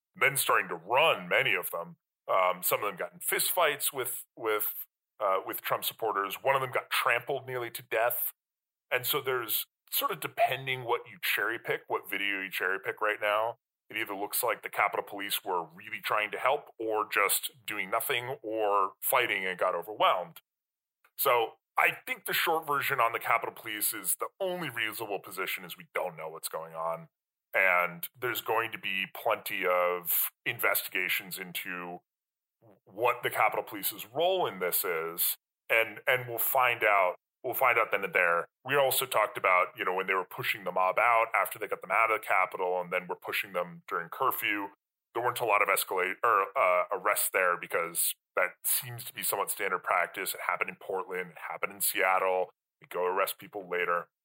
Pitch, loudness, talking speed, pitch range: 110 Hz, -29 LUFS, 190 wpm, 90-140 Hz